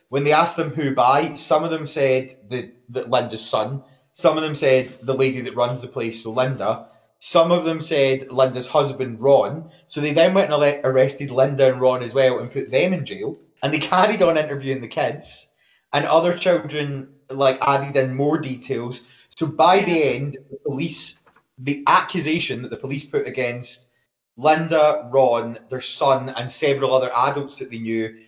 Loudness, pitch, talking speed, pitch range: -20 LUFS, 135 Hz, 185 wpm, 130-150 Hz